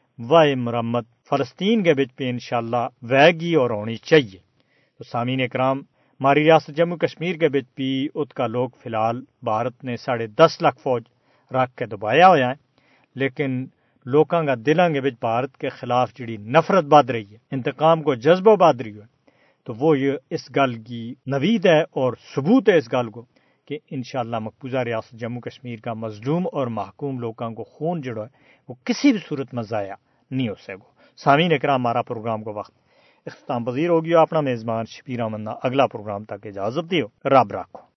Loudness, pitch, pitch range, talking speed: -21 LUFS, 130 Hz, 120-150 Hz, 180 wpm